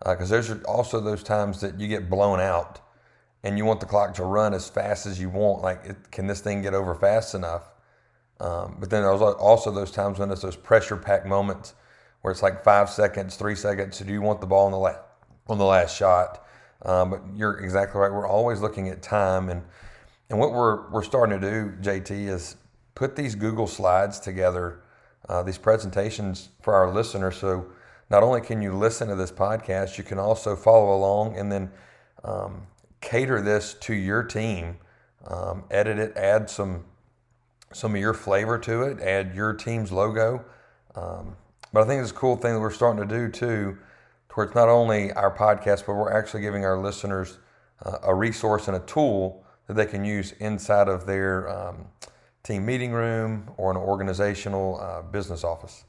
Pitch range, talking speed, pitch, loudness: 95-110 Hz, 195 wpm, 100 Hz, -24 LUFS